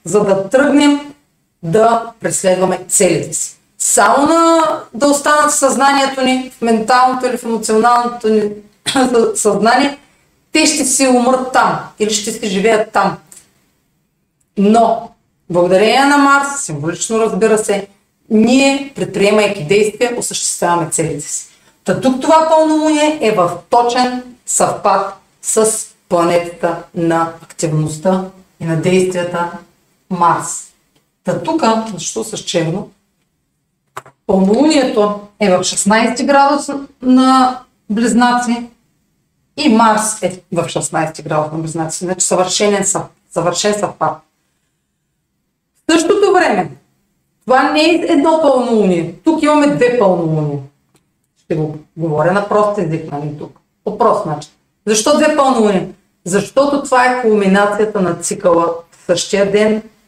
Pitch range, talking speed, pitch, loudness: 180-255 Hz, 120 wpm, 210 Hz, -13 LUFS